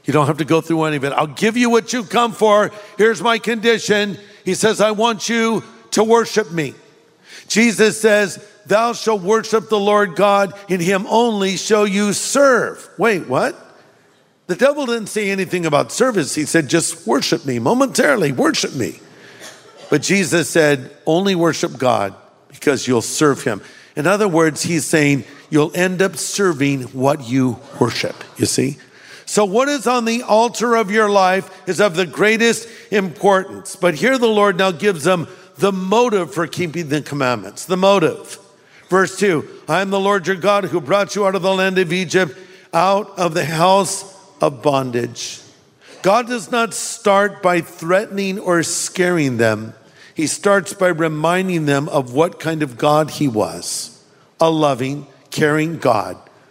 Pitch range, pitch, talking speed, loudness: 155-210 Hz, 185 Hz, 170 wpm, -17 LUFS